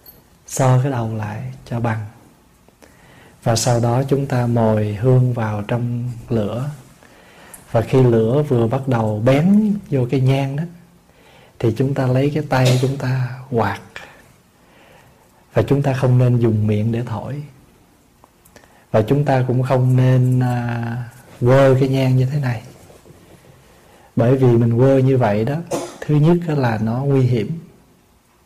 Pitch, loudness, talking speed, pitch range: 125 Hz, -18 LUFS, 150 wpm, 115-135 Hz